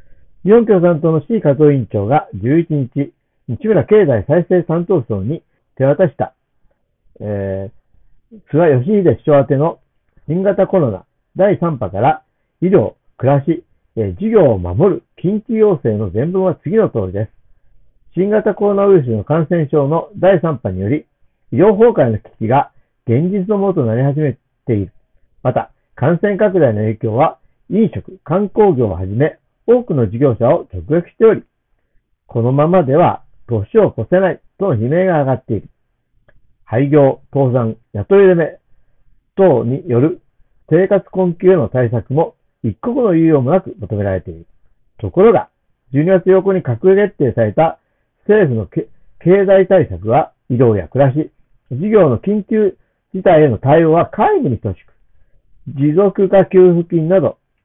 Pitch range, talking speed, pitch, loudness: 120-190 Hz, 270 characters per minute, 150 Hz, -14 LUFS